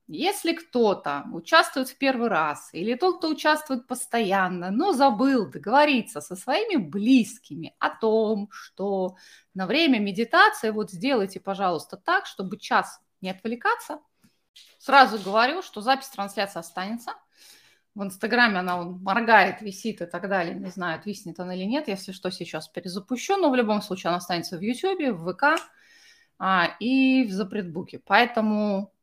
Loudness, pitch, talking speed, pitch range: -24 LUFS, 220 Hz, 145 wpm, 190-270 Hz